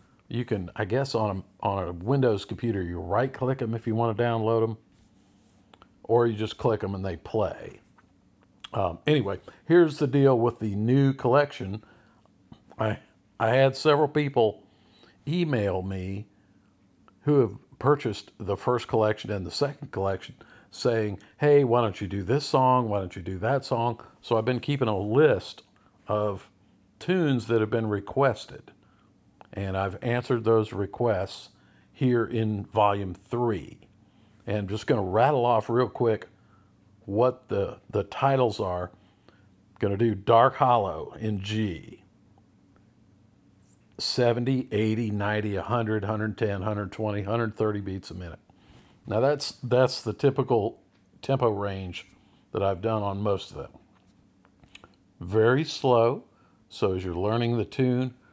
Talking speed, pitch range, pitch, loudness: 145 wpm, 100-125 Hz, 110 Hz, -26 LUFS